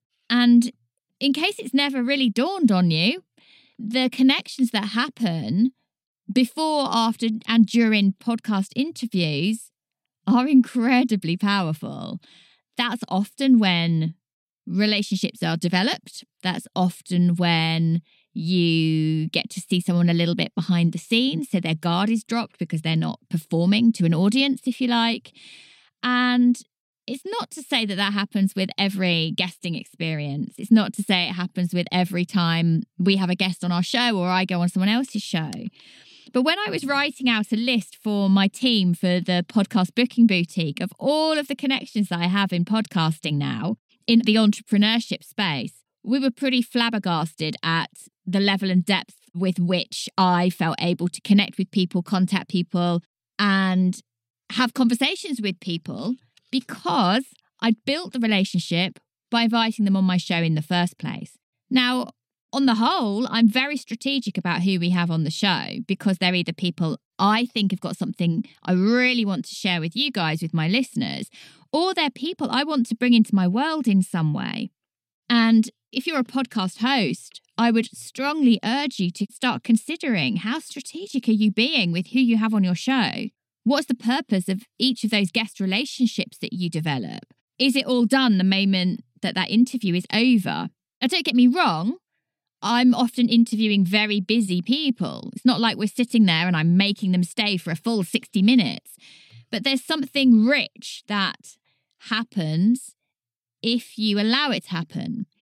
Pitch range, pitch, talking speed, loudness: 180-245 Hz, 210 Hz, 170 wpm, -22 LUFS